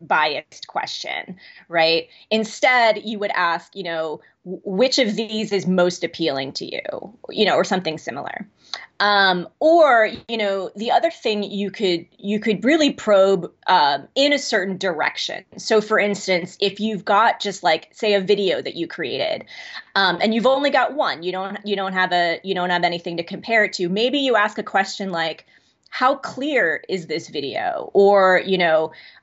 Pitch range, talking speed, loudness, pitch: 180-220 Hz, 180 wpm, -20 LUFS, 200 Hz